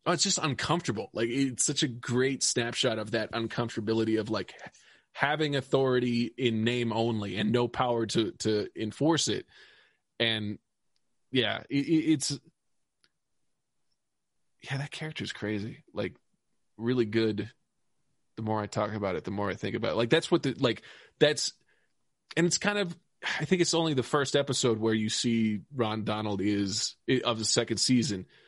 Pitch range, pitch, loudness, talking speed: 110-145 Hz, 120 Hz, -29 LUFS, 165 wpm